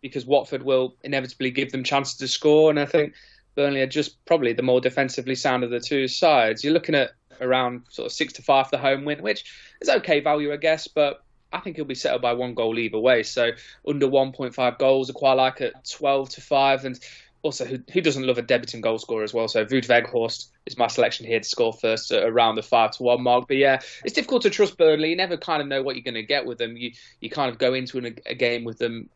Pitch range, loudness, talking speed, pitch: 125-145 Hz, -23 LUFS, 255 wpm, 135 Hz